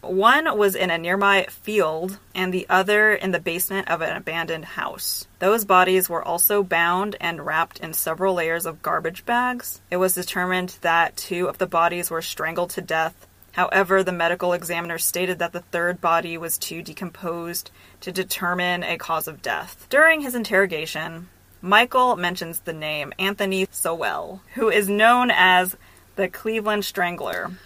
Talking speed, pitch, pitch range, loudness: 165 wpm, 180 Hz, 170-195 Hz, -21 LUFS